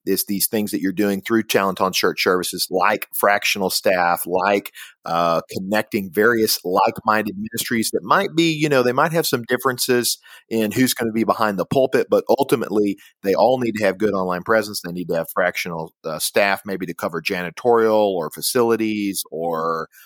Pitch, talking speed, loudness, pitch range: 110 Hz, 185 wpm, -20 LUFS, 95-125 Hz